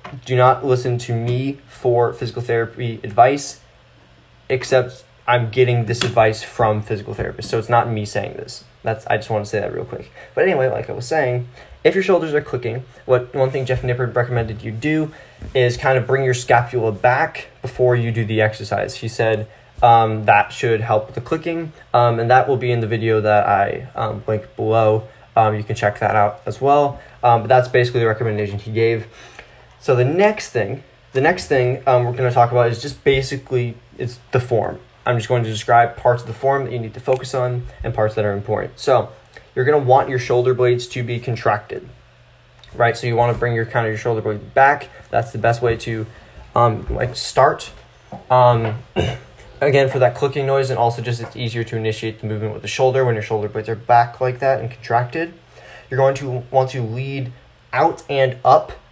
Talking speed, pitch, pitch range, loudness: 215 wpm, 120 Hz, 110-130 Hz, -18 LUFS